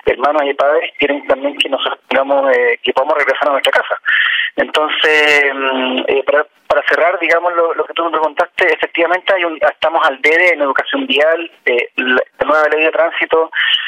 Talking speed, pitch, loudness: 185 wpm, 170 Hz, -13 LUFS